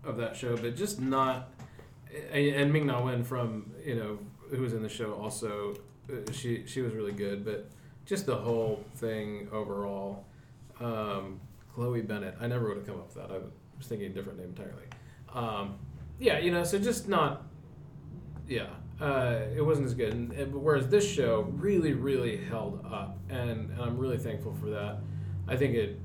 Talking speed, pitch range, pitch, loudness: 185 wpm, 105-140 Hz, 120 Hz, -32 LUFS